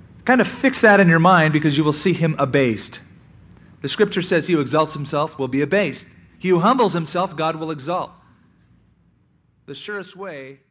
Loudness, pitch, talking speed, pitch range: -18 LUFS, 160 Hz, 190 wpm, 140-185 Hz